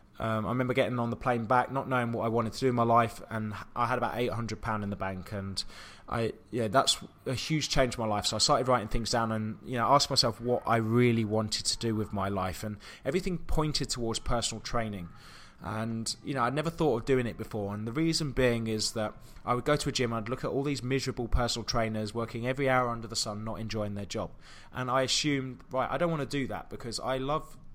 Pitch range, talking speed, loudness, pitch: 110-130 Hz, 260 wpm, -30 LUFS, 115 Hz